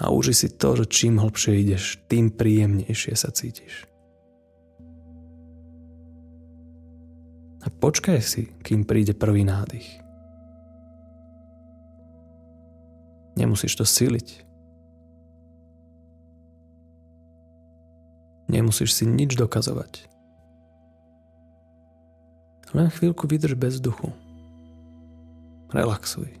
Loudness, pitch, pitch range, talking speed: -22 LUFS, 80 Hz, 80-105 Hz, 75 wpm